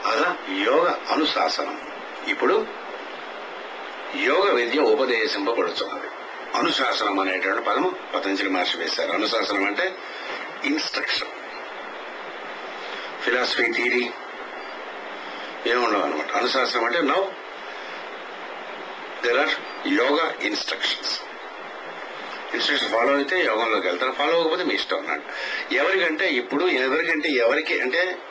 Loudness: -23 LUFS